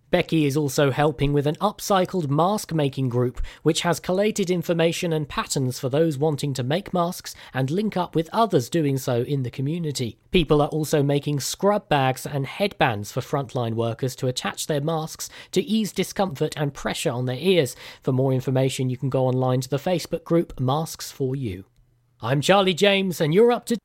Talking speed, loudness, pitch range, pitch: 190 wpm, -23 LUFS, 130-175 Hz, 150 Hz